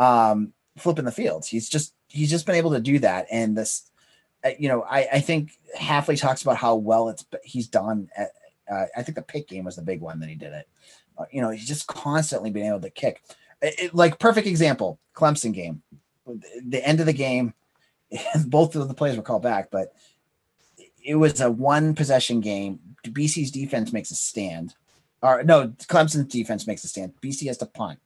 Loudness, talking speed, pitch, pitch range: -23 LUFS, 205 wpm, 135 Hz, 115-150 Hz